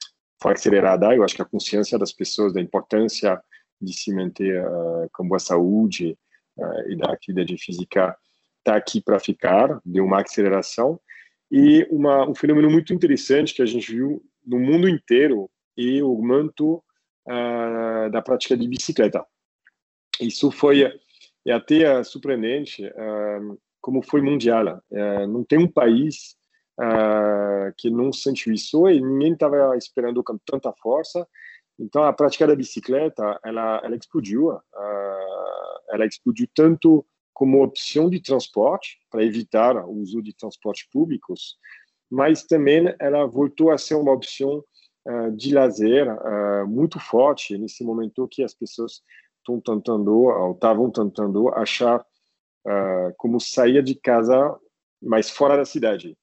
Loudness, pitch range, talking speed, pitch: -21 LUFS, 105-145 Hz, 145 wpm, 120 Hz